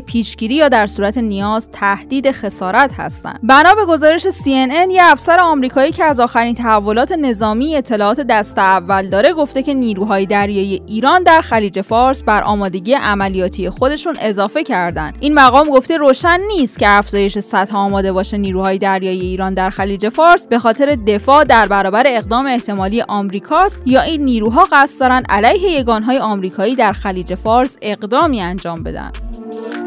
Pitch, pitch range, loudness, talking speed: 230 Hz, 200-275 Hz, -13 LUFS, 155 wpm